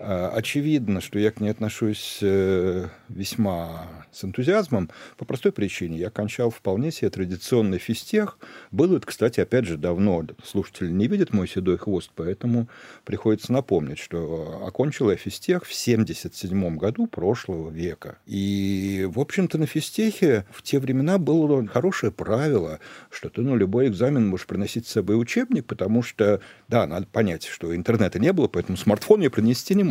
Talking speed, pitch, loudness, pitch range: 160 wpm, 105 Hz, -24 LUFS, 95-125 Hz